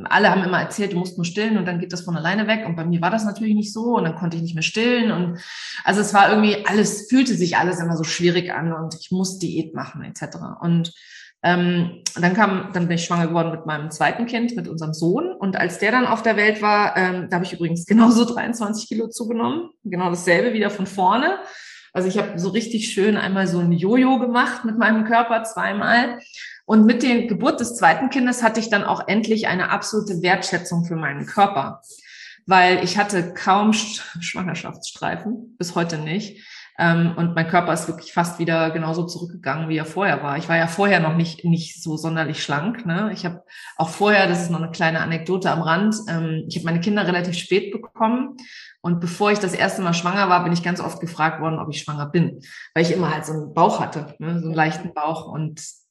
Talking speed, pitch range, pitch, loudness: 215 wpm, 170-215 Hz, 180 Hz, -20 LUFS